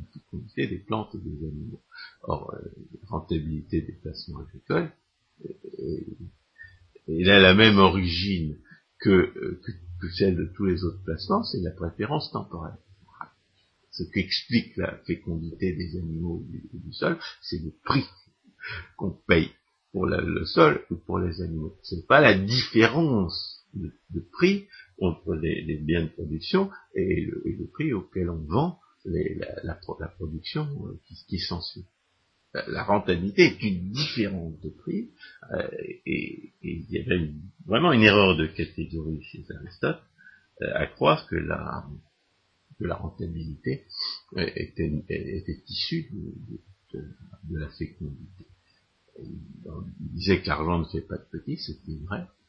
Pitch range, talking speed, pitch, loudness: 80-105 Hz, 145 wpm, 90 Hz, -26 LUFS